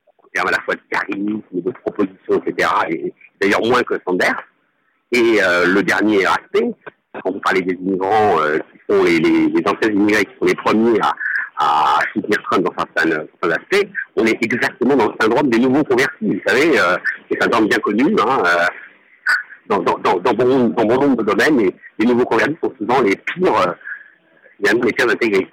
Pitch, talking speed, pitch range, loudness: 370 Hz, 195 wpm, 330-400 Hz, -16 LUFS